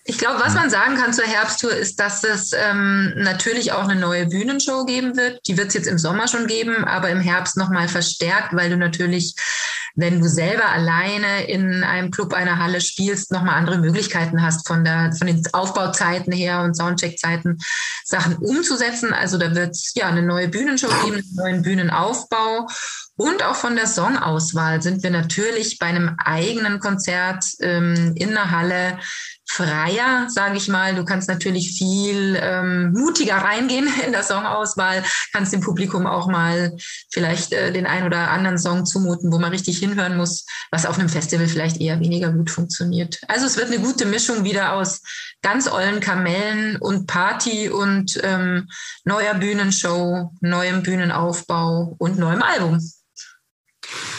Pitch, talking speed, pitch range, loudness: 185 Hz, 170 wpm, 175-205 Hz, -19 LUFS